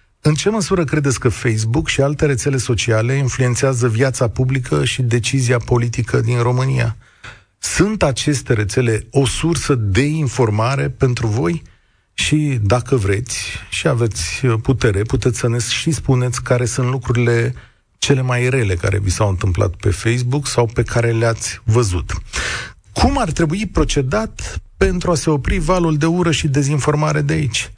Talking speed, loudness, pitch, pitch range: 150 wpm, -17 LUFS, 125 Hz, 115-145 Hz